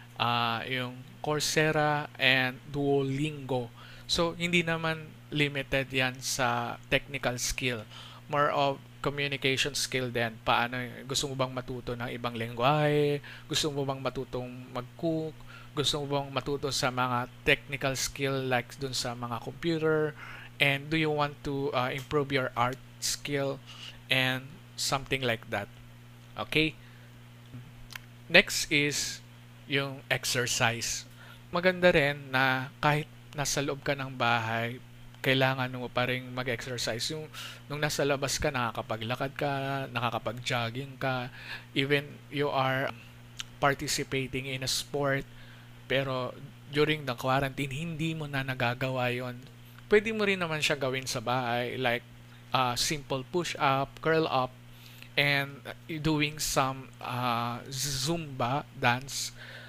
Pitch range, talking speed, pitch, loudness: 120-145 Hz, 120 wpm, 130 Hz, -30 LUFS